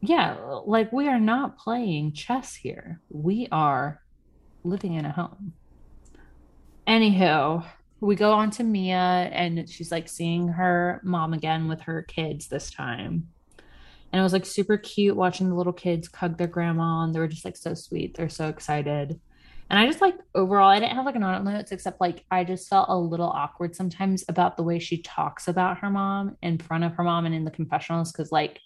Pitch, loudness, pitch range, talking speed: 175 Hz, -25 LUFS, 160-195 Hz, 200 wpm